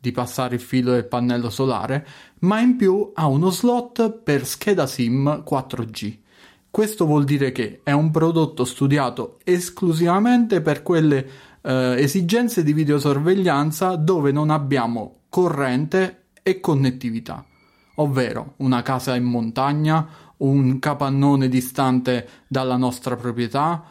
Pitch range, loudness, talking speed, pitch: 125-170 Hz, -20 LUFS, 125 wpm, 140 Hz